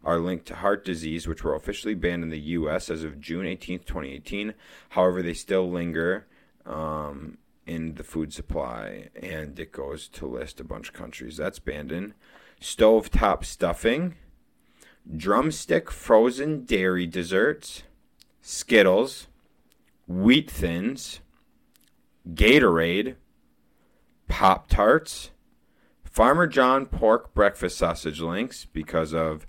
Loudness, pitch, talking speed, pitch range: -24 LUFS, 85 Hz, 120 wpm, 80-100 Hz